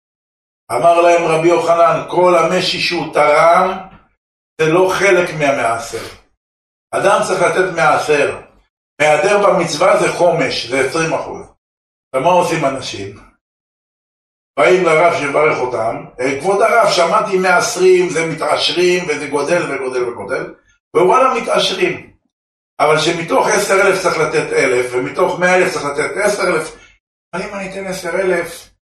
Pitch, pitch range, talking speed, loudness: 170 Hz, 145-180 Hz, 125 wpm, -14 LUFS